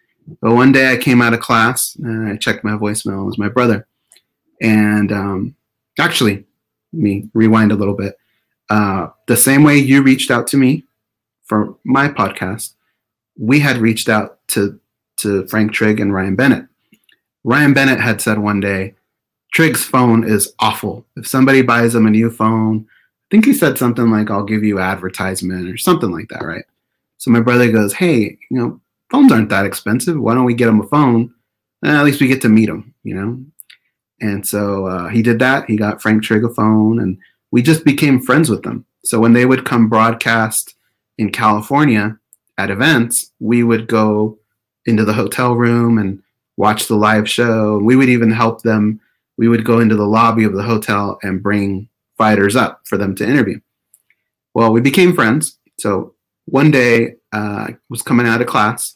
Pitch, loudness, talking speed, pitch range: 110 Hz, -14 LUFS, 190 wpm, 105-120 Hz